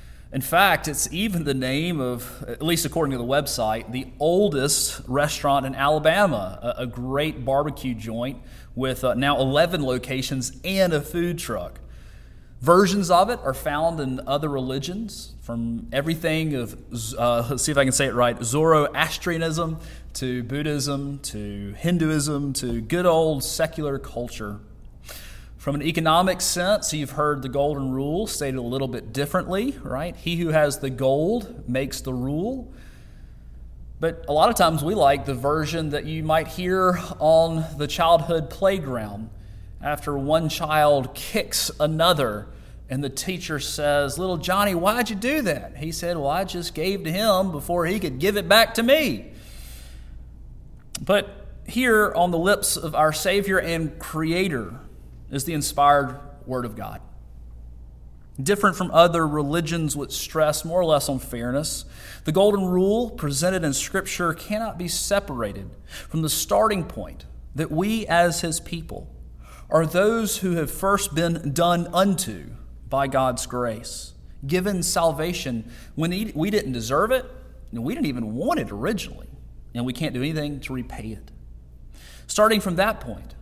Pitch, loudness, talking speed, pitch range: 150 Hz, -23 LUFS, 155 wpm, 130-170 Hz